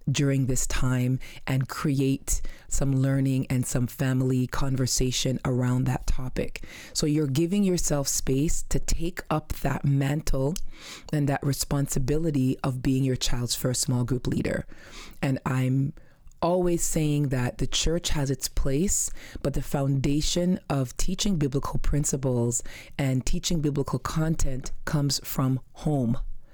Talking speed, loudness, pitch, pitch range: 135 wpm, -27 LUFS, 135 Hz, 130-150 Hz